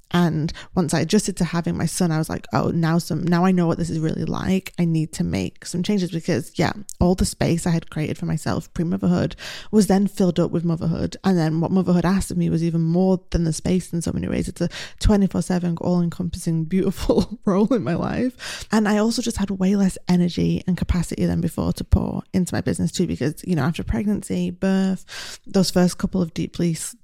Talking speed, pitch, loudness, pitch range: 220 wpm, 180 Hz, -22 LUFS, 170-190 Hz